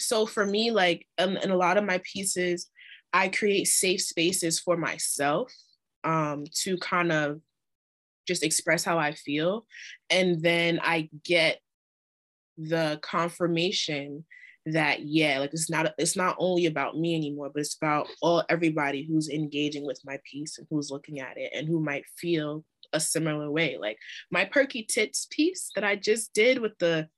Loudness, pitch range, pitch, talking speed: -27 LUFS, 150-180 Hz, 165 Hz, 170 wpm